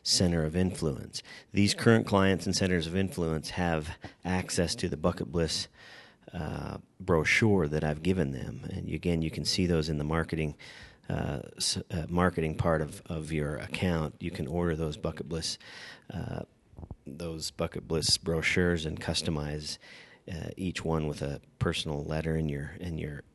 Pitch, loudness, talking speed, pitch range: 85 Hz, -31 LUFS, 165 wpm, 80-90 Hz